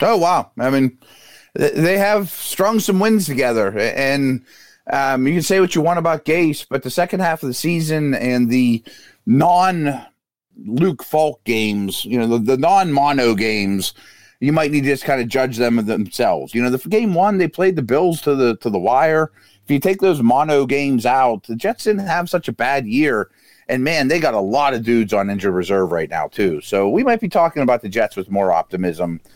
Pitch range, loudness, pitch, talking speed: 120-170 Hz, -17 LUFS, 140 Hz, 215 wpm